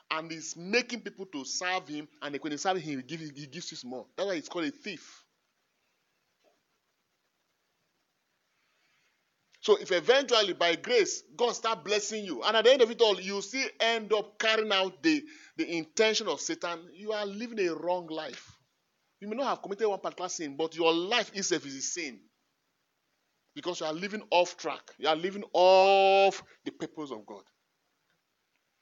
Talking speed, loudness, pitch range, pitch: 180 wpm, -29 LUFS, 165-220 Hz, 195 Hz